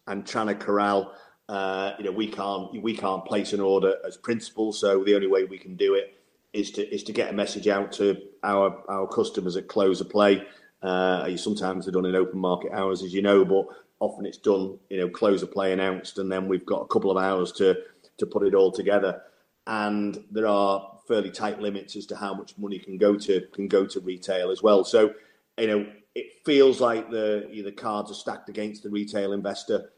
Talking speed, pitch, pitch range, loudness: 225 wpm, 100 Hz, 95-105 Hz, -25 LUFS